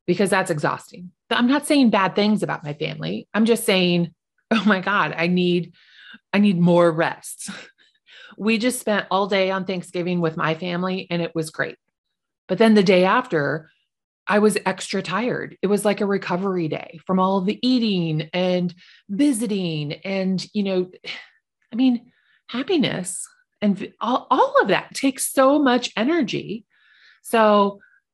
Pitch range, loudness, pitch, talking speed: 180-225 Hz, -21 LUFS, 195 Hz, 160 wpm